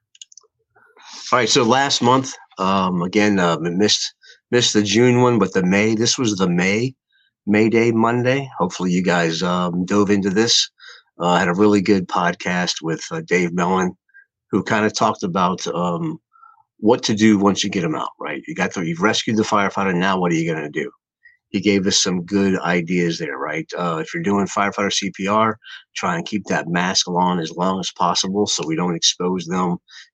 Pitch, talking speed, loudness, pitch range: 100 Hz, 195 wpm, -19 LUFS, 90-120 Hz